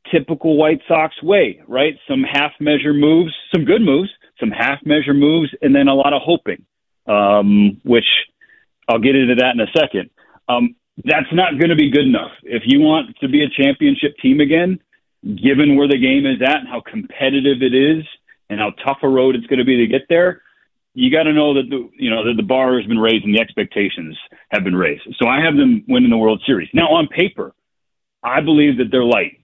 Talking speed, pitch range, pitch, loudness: 220 wpm, 130-185 Hz, 150 Hz, -15 LUFS